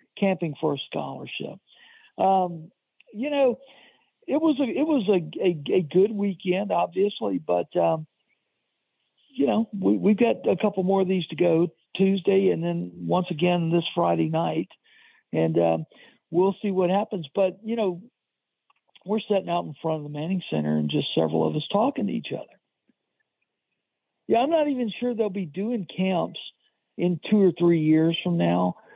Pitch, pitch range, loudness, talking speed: 185 Hz, 160-210 Hz, -25 LUFS, 170 wpm